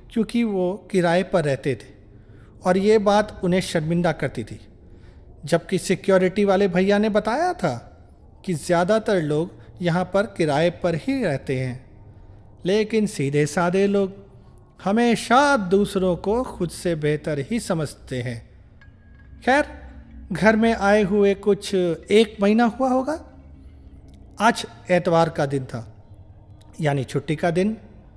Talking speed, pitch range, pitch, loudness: 130 wpm, 120-200 Hz, 175 Hz, -21 LUFS